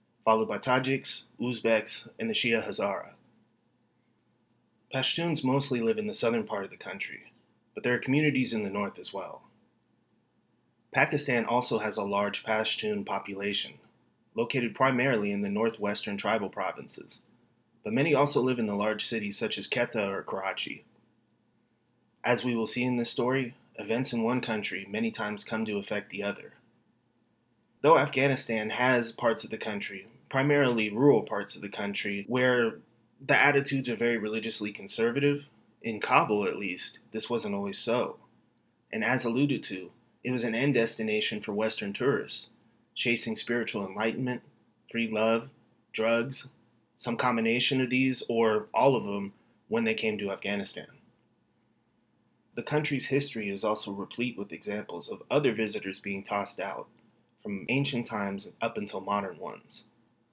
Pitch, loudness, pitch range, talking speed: 115 Hz, -29 LUFS, 110-130 Hz, 150 wpm